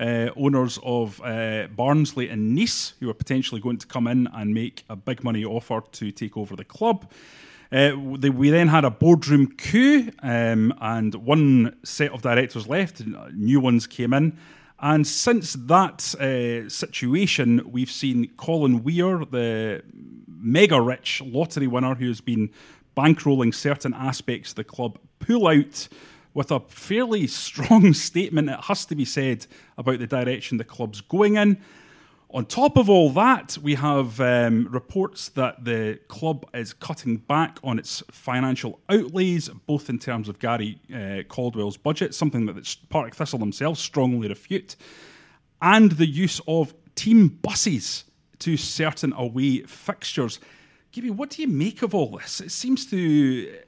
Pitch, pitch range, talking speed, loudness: 135 Hz, 120-160 Hz, 160 wpm, -22 LUFS